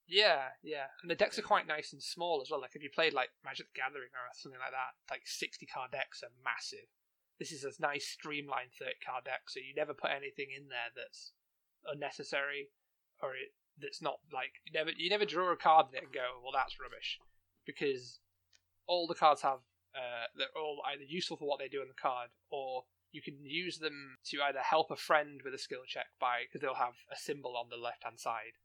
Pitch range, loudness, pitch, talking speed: 135-190 Hz, -37 LUFS, 155 Hz, 220 wpm